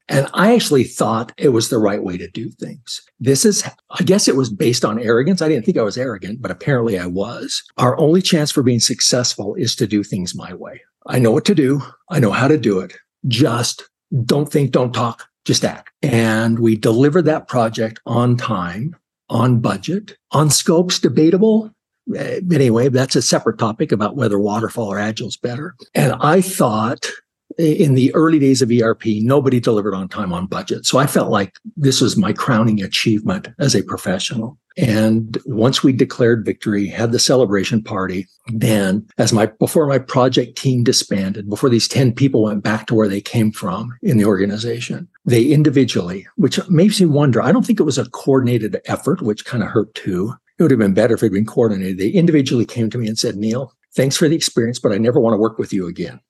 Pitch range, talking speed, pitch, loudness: 110-150 Hz, 205 wpm, 125 Hz, -16 LUFS